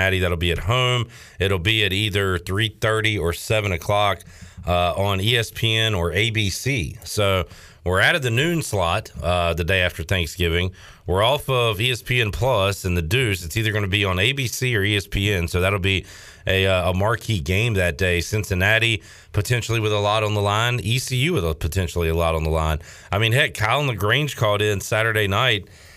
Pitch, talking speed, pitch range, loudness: 100 Hz, 190 wpm, 90-110 Hz, -21 LUFS